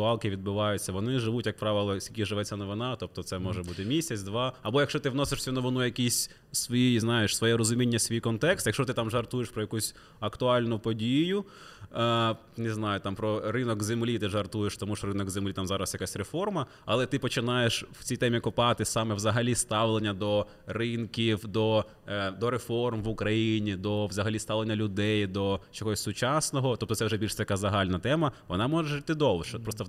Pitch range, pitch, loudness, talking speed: 105-120 Hz, 110 Hz, -29 LUFS, 185 wpm